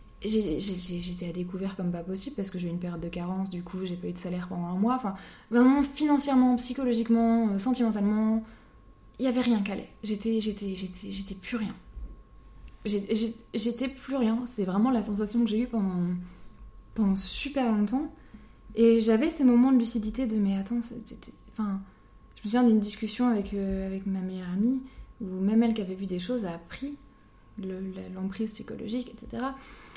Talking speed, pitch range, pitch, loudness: 190 wpm, 190-235 Hz, 215 Hz, -28 LUFS